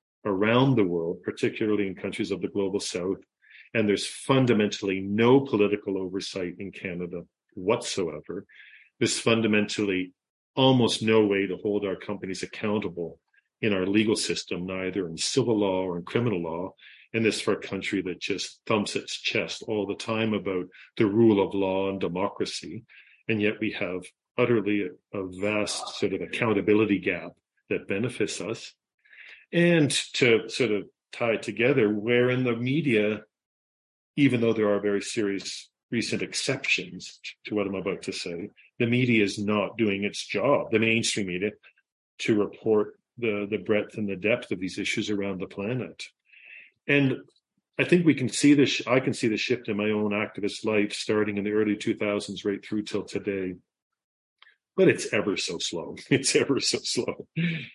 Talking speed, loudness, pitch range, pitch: 165 wpm, -26 LUFS, 100-115 Hz, 105 Hz